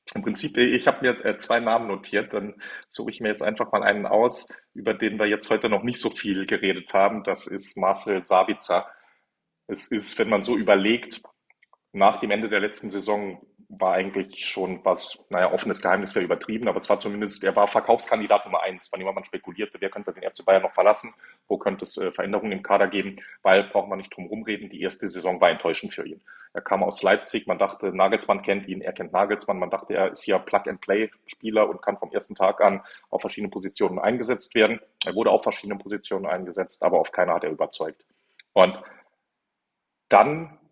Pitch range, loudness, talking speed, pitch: 100-110 Hz, -24 LUFS, 200 wpm, 100 Hz